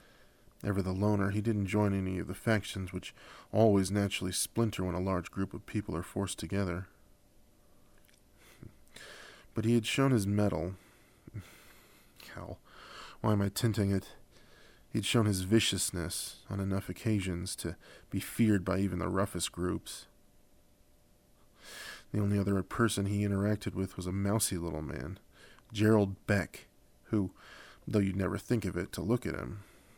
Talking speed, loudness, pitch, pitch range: 150 wpm, -33 LUFS, 100 Hz, 95-105 Hz